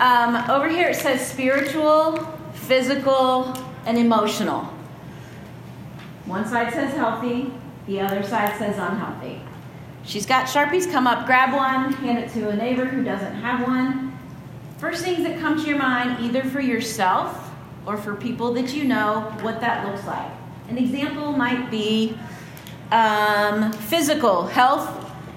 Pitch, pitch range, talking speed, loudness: 245 Hz, 215-270 Hz, 145 wpm, -22 LUFS